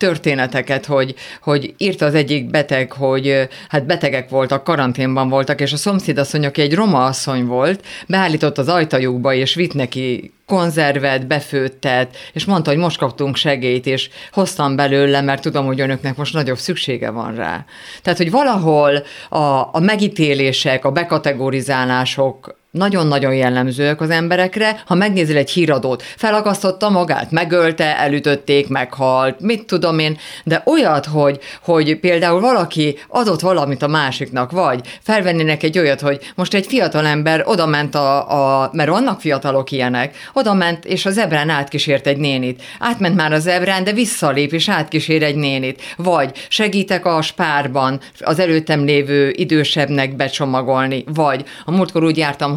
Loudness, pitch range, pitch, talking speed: -16 LUFS, 135-175 Hz, 150 Hz, 150 wpm